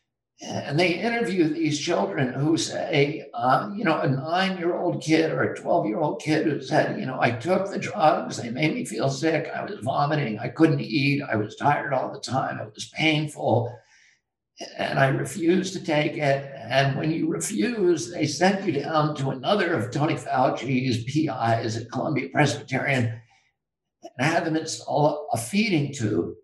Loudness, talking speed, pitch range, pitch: -24 LUFS, 180 wpm, 135-170 Hz, 155 Hz